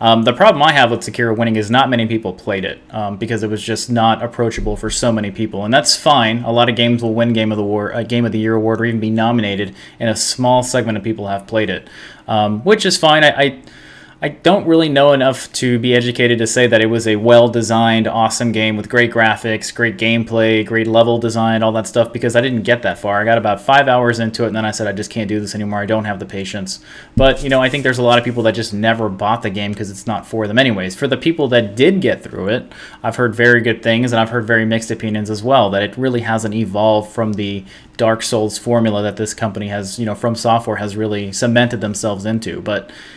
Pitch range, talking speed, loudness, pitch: 110-120 Hz, 260 wpm, -15 LUFS, 115 Hz